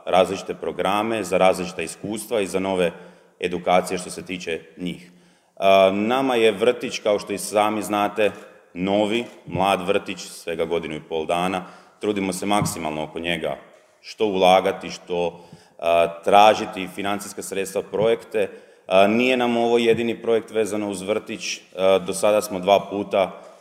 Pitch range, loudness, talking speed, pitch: 90-110 Hz, -22 LUFS, 135 wpm, 100 Hz